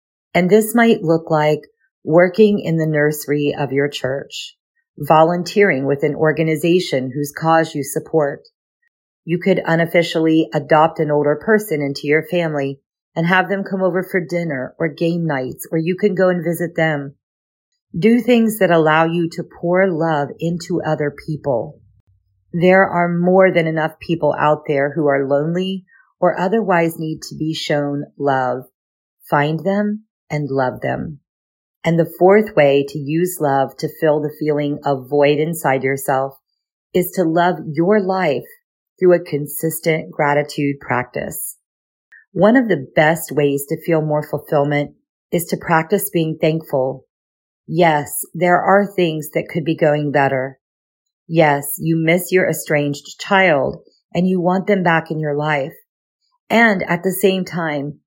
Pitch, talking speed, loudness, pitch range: 160 Hz, 155 wpm, -17 LUFS, 145-180 Hz